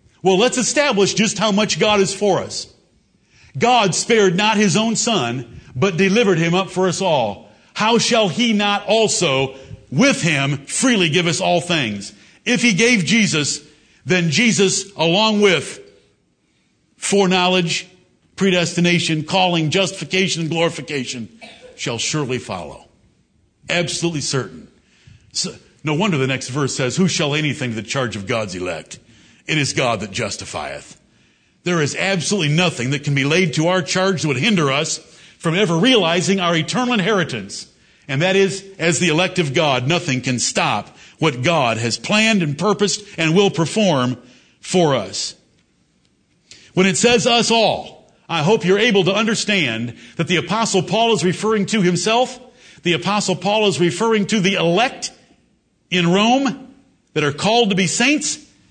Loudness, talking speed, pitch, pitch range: -17 LUFS, 155 wpm, 180 Hz, 150-210 Hz